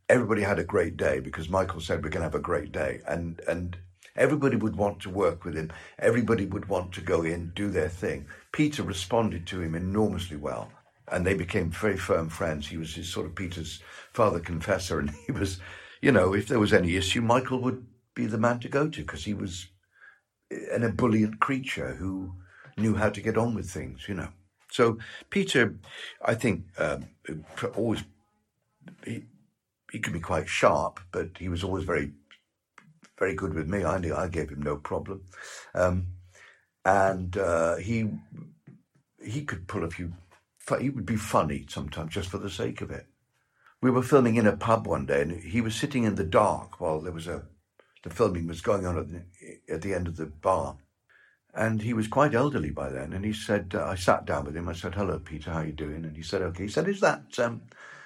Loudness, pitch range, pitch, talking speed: -28 LUFS, 85-110 Hz, 95 Hz, 205 wpm